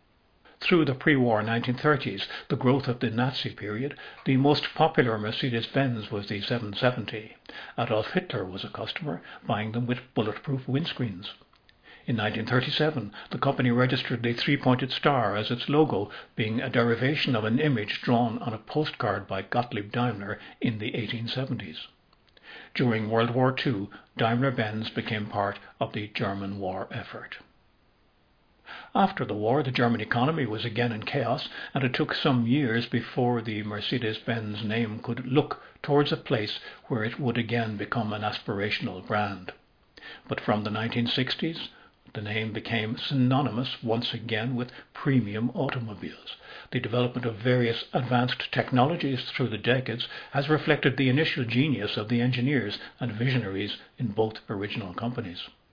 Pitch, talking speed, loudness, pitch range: 120 Hz, 150 wpm, -28 LUFS, 110-130 Hz